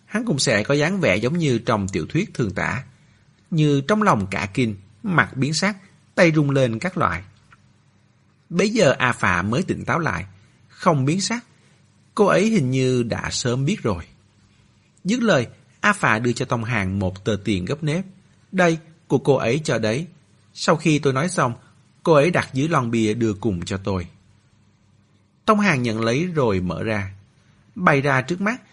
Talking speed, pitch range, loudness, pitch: 190 wpm, 110-160 Hz, -21 LUFS, 130 Hz